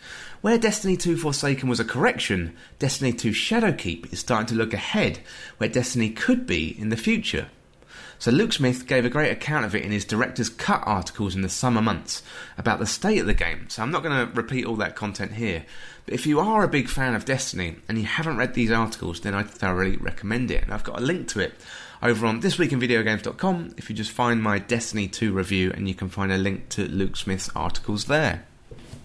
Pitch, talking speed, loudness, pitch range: 115 Hz, 215 wpm, -24 LUFS, 100-130 Hz